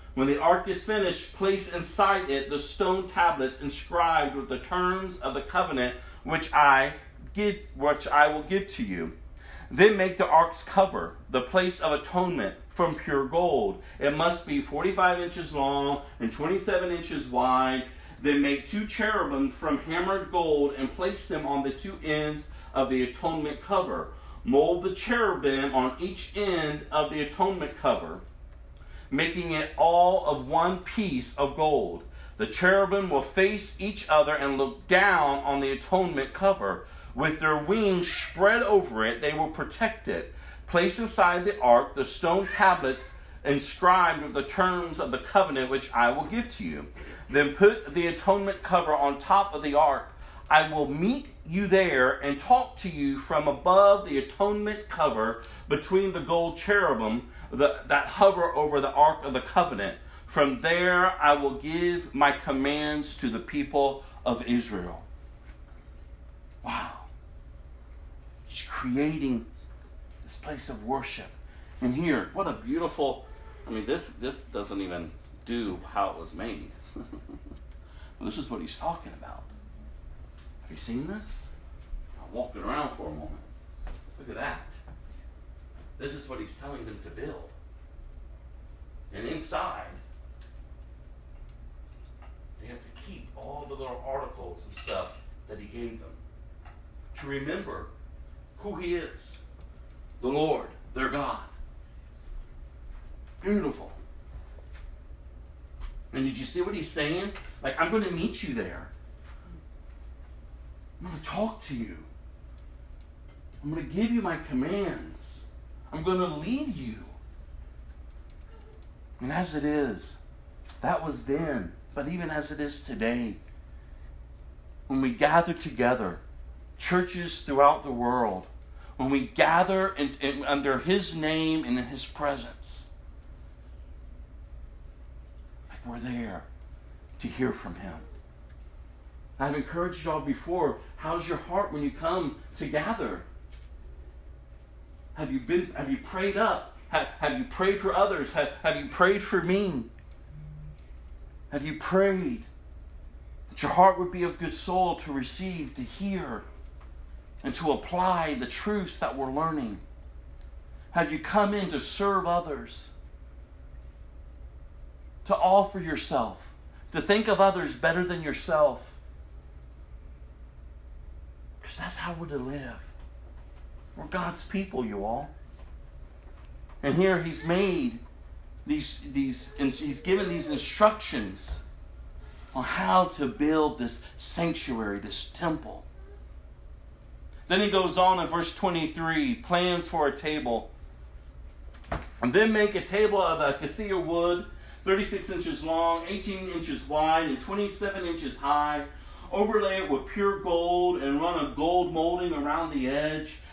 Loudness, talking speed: -27 LUFS, 140 wpm